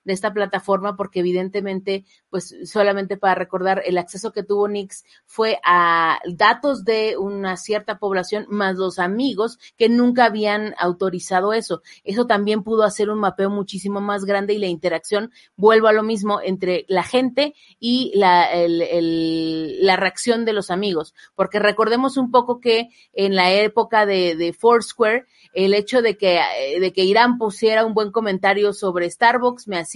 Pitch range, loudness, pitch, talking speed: 185-220 Hz, -19 LUFS, 200 Hz, 165 wpm